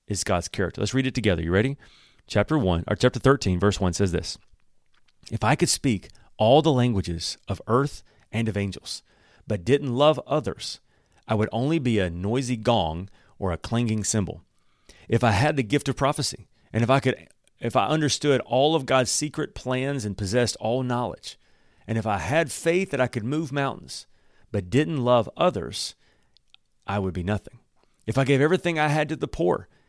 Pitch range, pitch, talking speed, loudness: 100-140 Hz, 120 Hz, 190 wpm, -24 LUFS